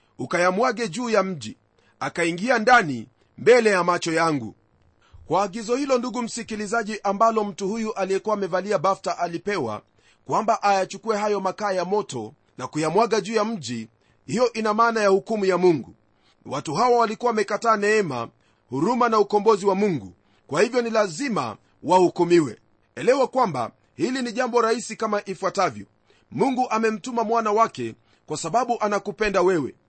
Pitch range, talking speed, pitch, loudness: 175-225 Hz, 145 wpm, 205 Hz, -22 LUFS